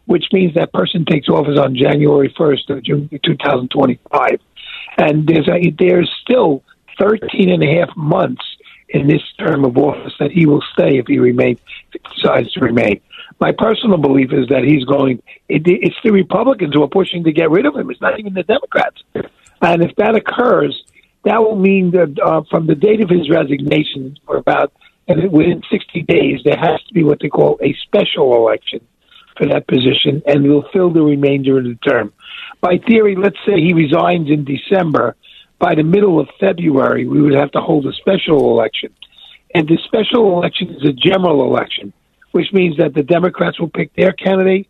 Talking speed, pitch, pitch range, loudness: 190 wpm, 165 Hz, 145-180 Hz, -14 LUFS